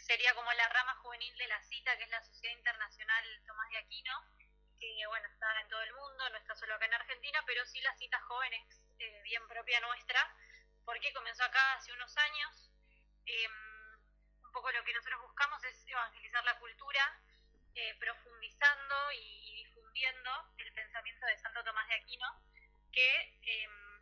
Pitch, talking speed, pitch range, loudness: 240 Hz, 170 wpm, 225-260 Hz, -36 LUFS